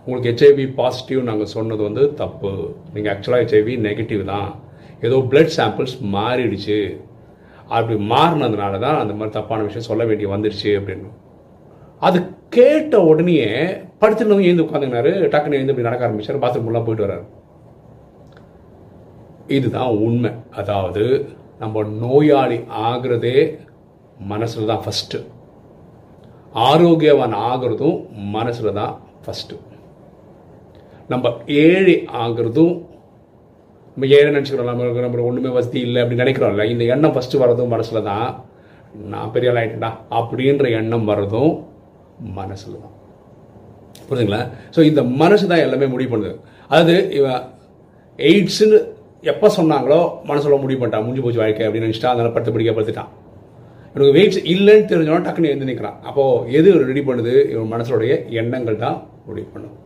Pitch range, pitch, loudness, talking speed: 110-145 Hz, 120 Hz, -17 LUFS, 125 wpm